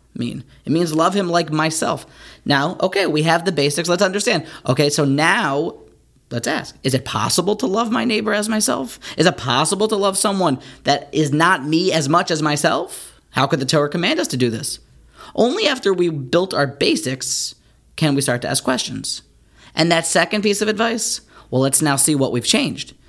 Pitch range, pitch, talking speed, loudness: 140-195 Hz, 160 Hz, 200 wpm, -18 LUFS